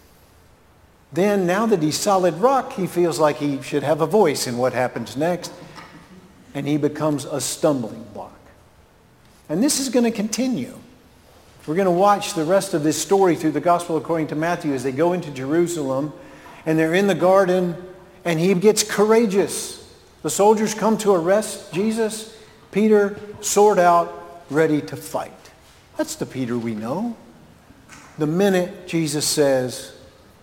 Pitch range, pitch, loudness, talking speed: 155-205 Hz, 175 Hz, -20 LUFS, 160 wpm